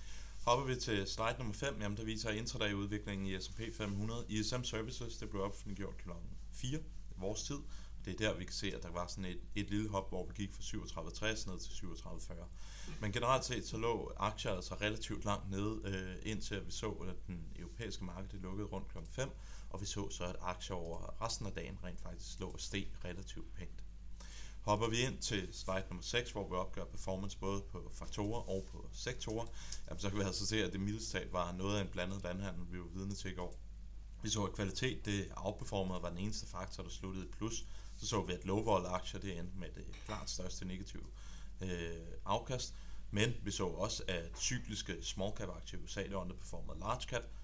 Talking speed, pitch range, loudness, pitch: 205 wpm, 90-105 Hz, -42 LUFS, 95 Hz